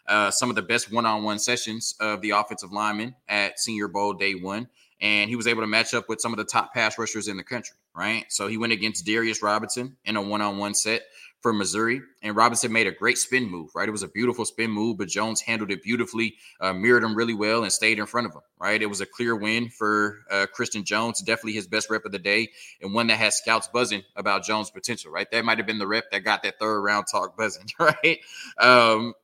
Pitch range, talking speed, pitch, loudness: 105-115 Hz, 240 wpm, 110 Hz, -24 LUFS